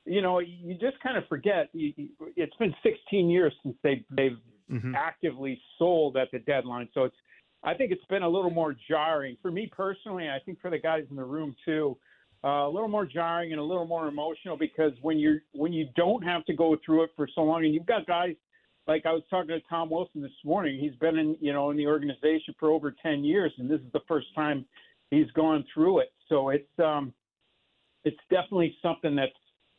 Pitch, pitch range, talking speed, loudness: 160 Hz, 145-180 Hz, 215 wpm, -29 LUFS